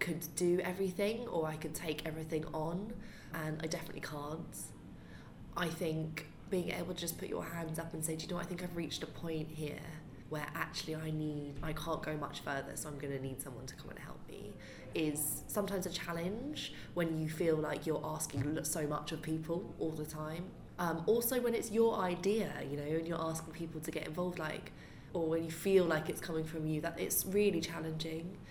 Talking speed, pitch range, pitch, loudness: 210 wpm, 155-175 Hz, 160 Hz, -38 LUFS